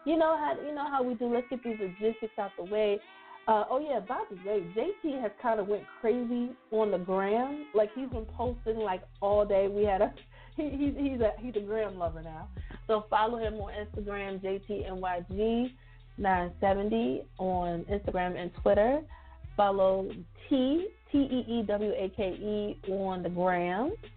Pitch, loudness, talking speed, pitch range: 210 Hz, -31 LUFS, 190 wpm, 195-245 Hz